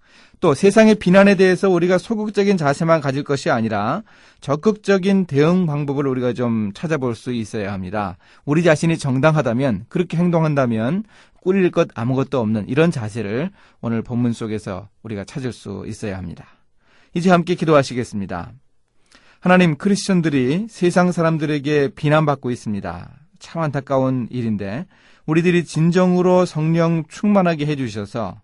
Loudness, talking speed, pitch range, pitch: -18 LUFS, 345 characters per minute, 115-175 Hz, 145 Hz